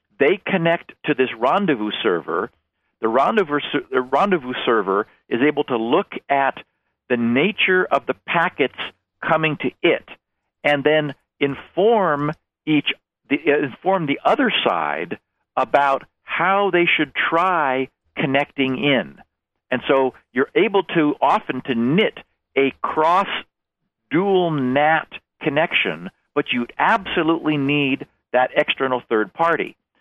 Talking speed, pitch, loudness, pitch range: 120 wpm, 145 Hz, -20 LUFS, 135-170 Hz